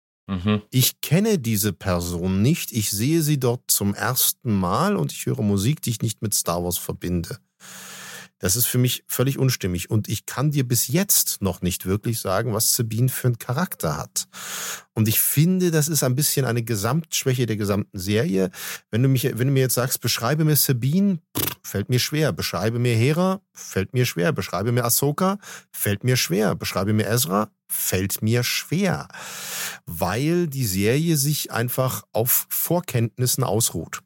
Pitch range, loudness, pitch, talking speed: 105-140 Hz, -22 LUFS, 120 Hz, 170 wpm